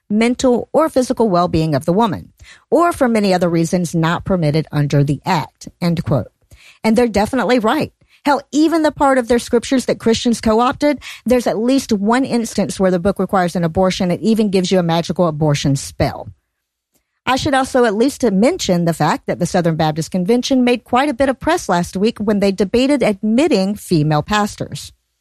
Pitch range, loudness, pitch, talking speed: 175-250 Hz, -16 LUFS, 215 Hz, 190 wpm